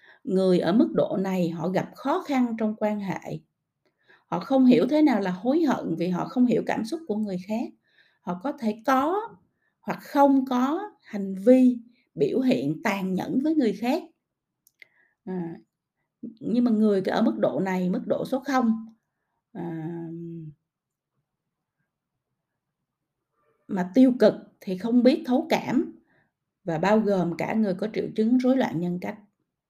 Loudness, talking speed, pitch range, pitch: -24 LUFS, 160 wpm, 185-260 Hz, 220 Hz